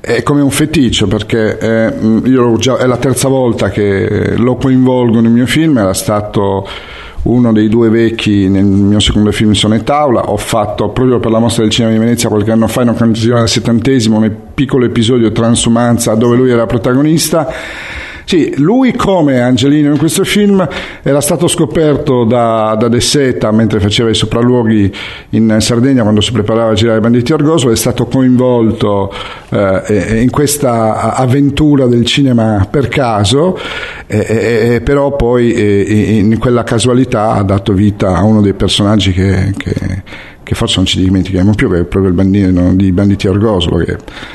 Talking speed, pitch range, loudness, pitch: 170 wpm, 105-125 Hz, -10 LUFS, 115 Hz